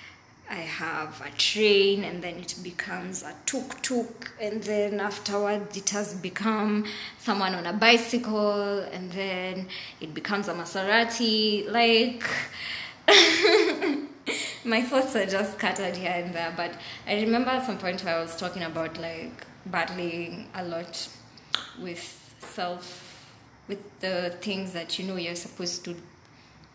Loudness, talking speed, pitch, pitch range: -26 LUFS, 135 wpm, 195 Hz, 175-215 Hz